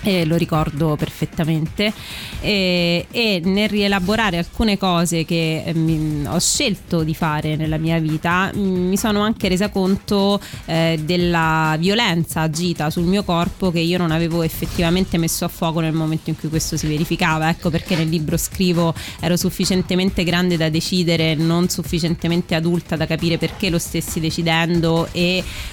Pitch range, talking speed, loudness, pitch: 160-185 Hz, 155 wpm, -19 LUFS, 170 Hz